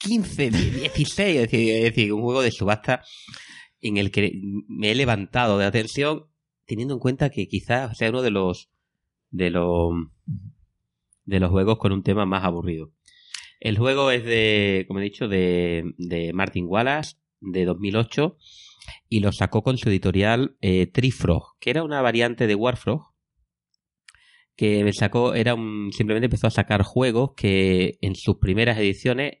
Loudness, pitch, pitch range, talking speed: -22 LUFS, 105 Hz, 95-125 Hz, 160 wpm